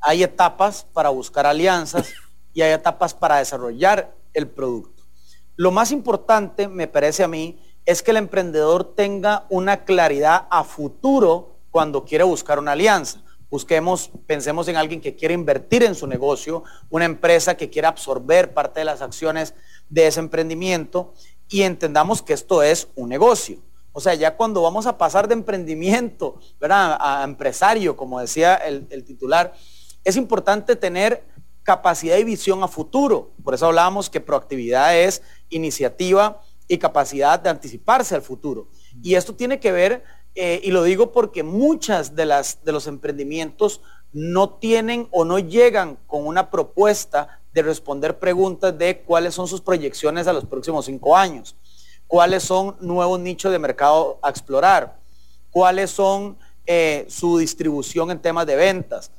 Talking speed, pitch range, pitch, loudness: 155 wpm, 150-195 Hz, 170 Hz, -19 LUFS